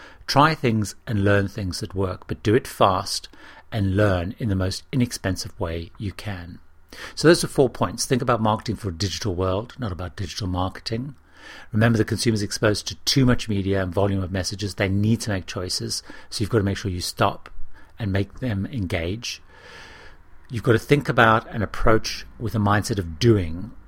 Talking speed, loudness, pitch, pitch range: 195 wpm, -23 LUFS, 100 Hz, 95-115 Hz